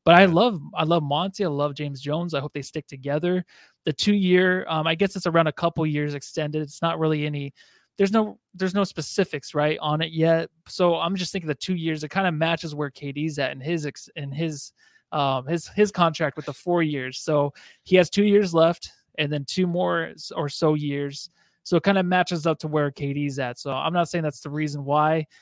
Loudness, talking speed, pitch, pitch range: -24 LUFS, 230 wpm, 160 Hz, 150-175 Hz